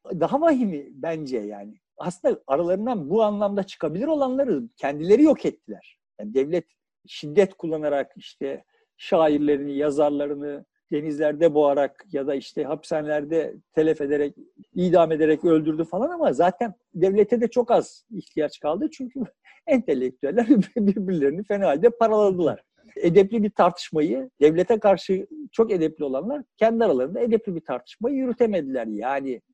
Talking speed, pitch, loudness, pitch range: 125 wpm, 175 Hz, -23 LUFS, 150-230 Hz